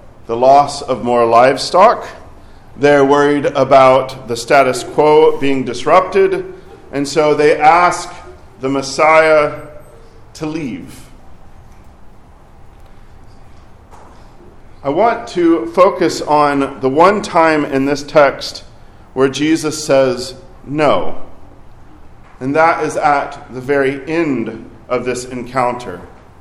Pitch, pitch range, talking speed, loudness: 135 Hz, 115-150 Hz, 105 wpm, -13 LUFS